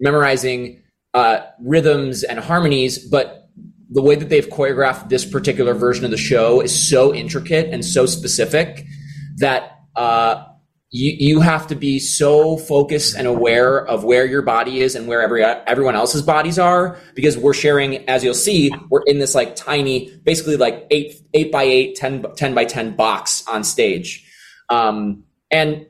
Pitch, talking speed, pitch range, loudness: 140 Hz, 165 wpm, 130-155 Hz, -16 LUFS